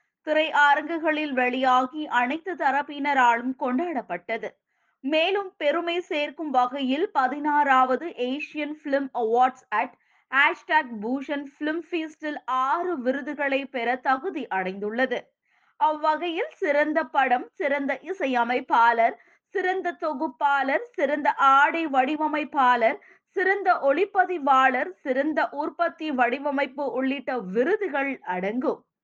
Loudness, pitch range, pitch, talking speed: -24 LUFS, 260-320 Hz, 290 Hz, 75 wpm